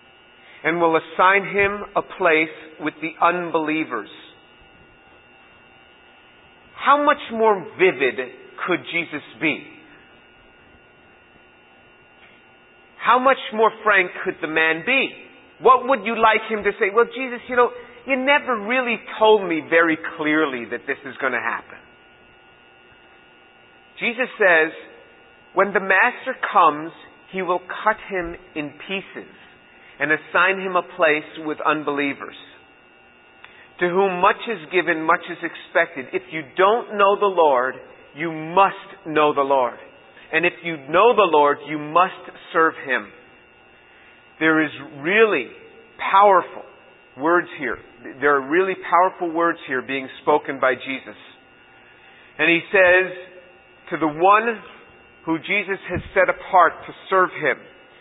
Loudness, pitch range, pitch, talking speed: -20 LUFS, 130-195 Hz, 165 Hz, 130 wpm